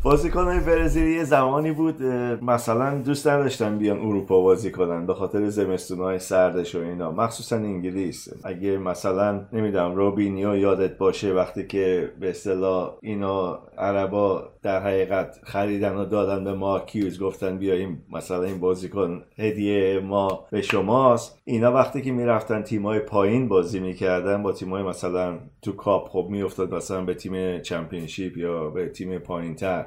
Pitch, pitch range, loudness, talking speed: 100 Hz, 95-110 Hz, -24 LUFS, 150 wpm